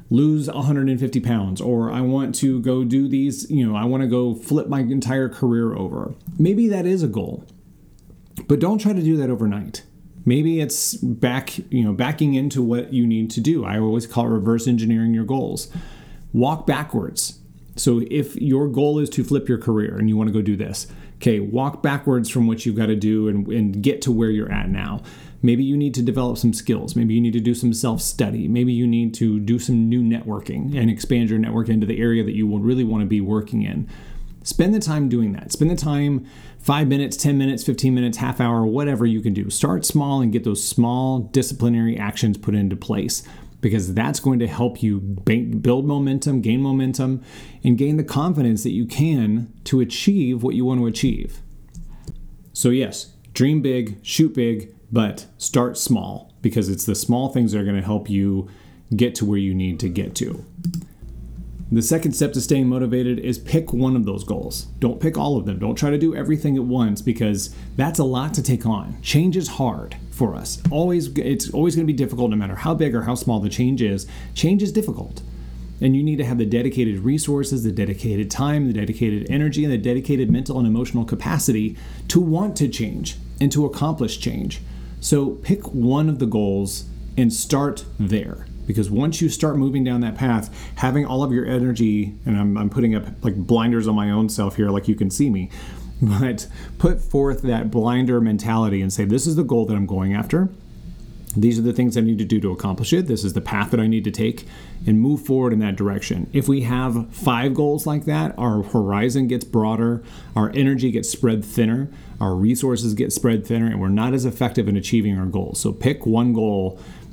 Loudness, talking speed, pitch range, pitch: -20 LUFS, 210 wpm, 110-135 Hz, 120 Hz